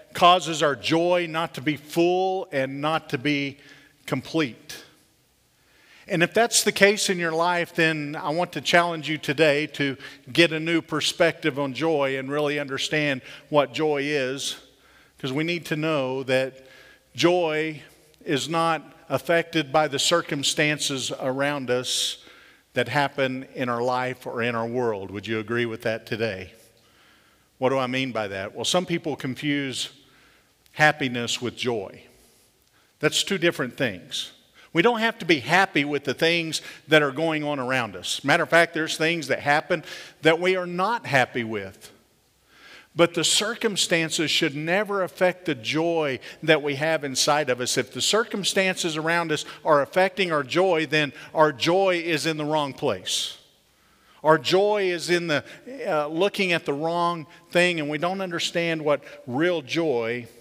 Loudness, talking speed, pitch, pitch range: -23 LUFS, 165 wpm, 155 Hz, 135-170 Hz